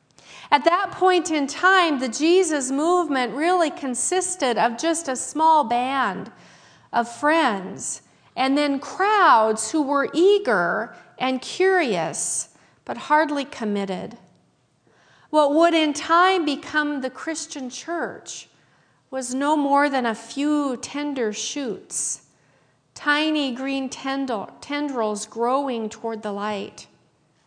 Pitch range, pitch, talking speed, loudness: 245-320 Hz, 285 Hz, 110 wpm, -22 LUFS